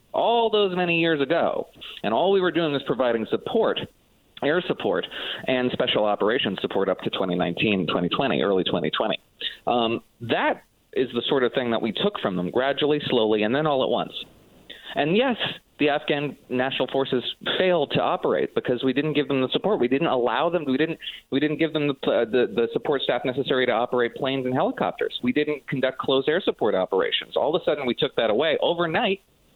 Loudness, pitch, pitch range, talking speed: -24 LUFS, 150 Hz, 130-180 Hz, 200 wpm